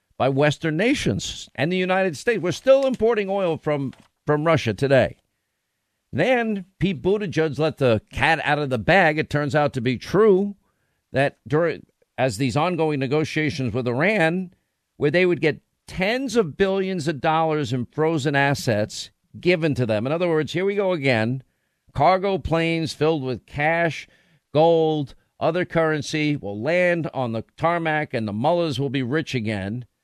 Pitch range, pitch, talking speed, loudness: 130-175 Hz, 155 Hz, 160 wpm, -22 LUFS